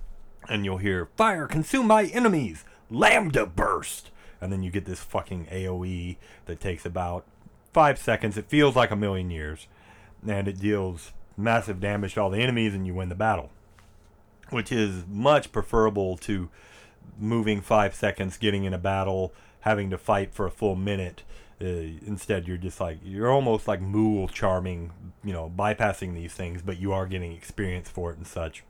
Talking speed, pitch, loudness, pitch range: 175 wpm, 100 Hz, -26 LUFS, 90-105 Hz